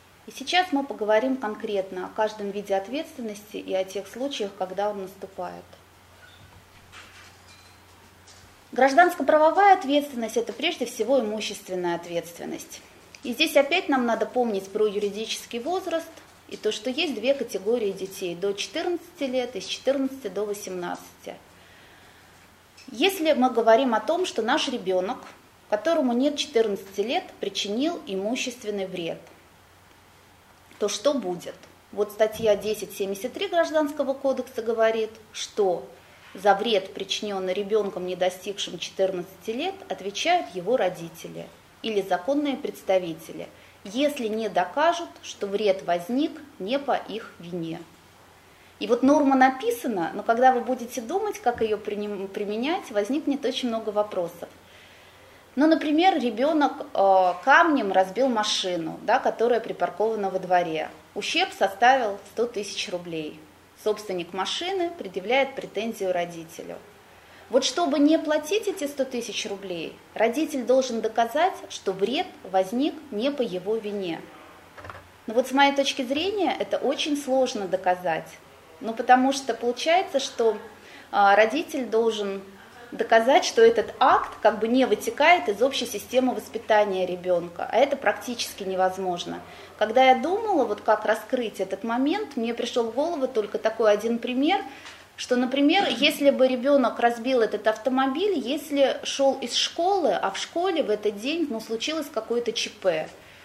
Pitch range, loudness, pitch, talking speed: 190-275 Hz, -25 LUFS, 220 Hz, 130 wpm